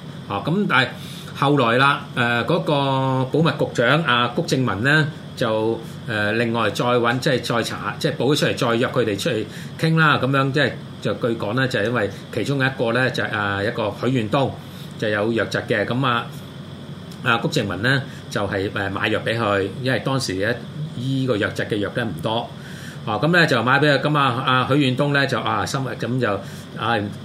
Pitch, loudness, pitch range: 130 Hz, -20 LUFS, 115-150 Hz